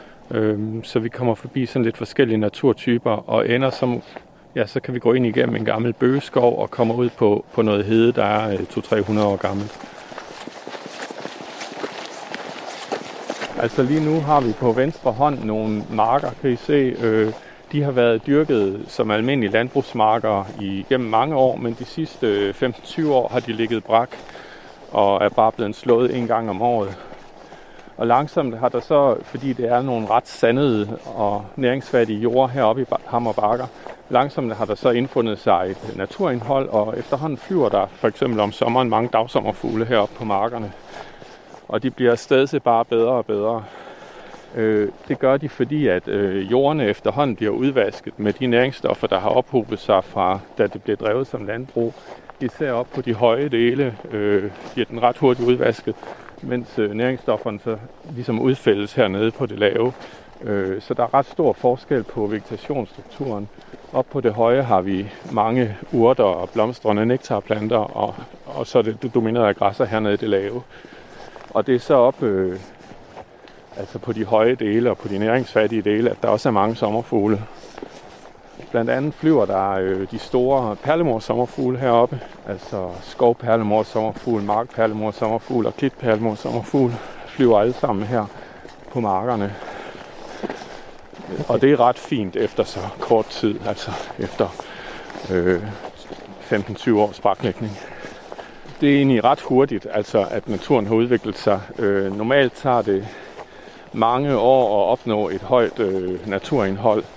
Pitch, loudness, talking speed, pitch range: 115 Hz, -20 LUFS, 155 wpm, 105-125 Hz